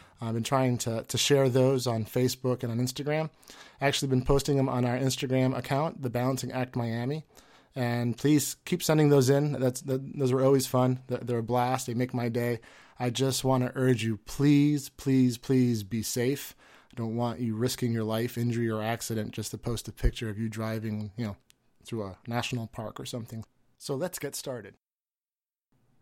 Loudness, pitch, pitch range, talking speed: -29 LUFS, 125 Hz, 115-135 Hz, 195 wpm